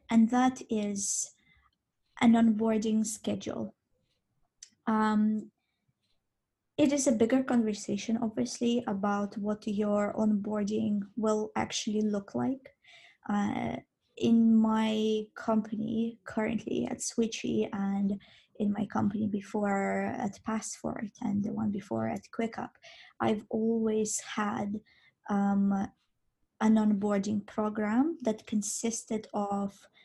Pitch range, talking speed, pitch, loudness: 205-230 Hz, 100 wpm, 215 Hz, -30 LUFS